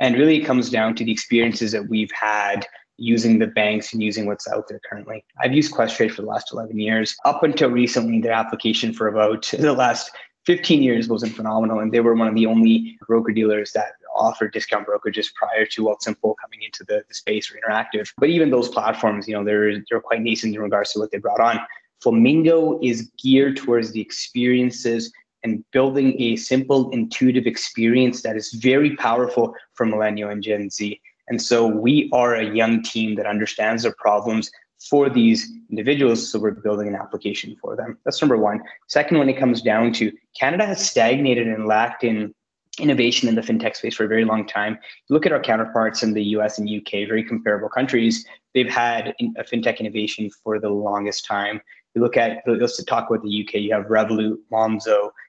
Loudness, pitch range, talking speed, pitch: -20 LUFS, 110-125 Hz, 200 wpm, 115 Hz